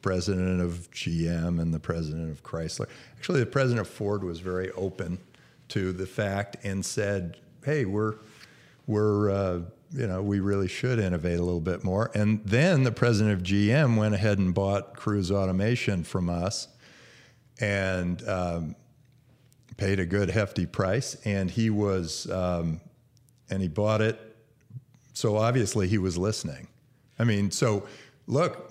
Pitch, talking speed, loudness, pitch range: 100 Hz, 155 wpm, -28 LUFS, 95-115 Hz